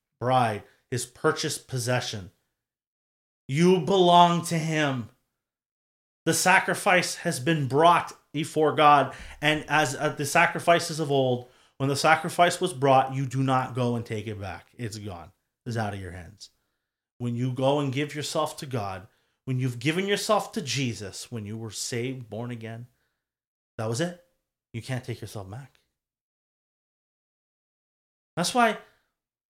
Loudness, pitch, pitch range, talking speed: -25 LUFS, 135 Hz, 120-160 Hz, 150 wpm